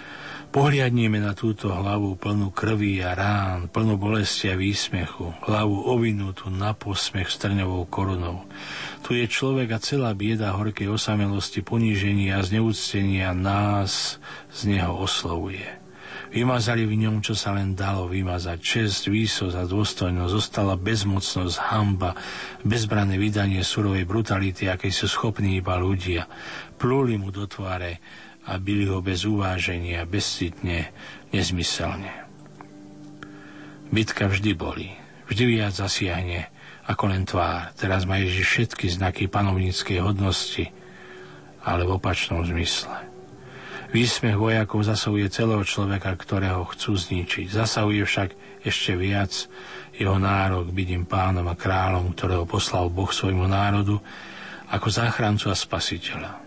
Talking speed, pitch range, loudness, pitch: 120 wpm, 95-105 Hz, -24 LUFS, 100 Hz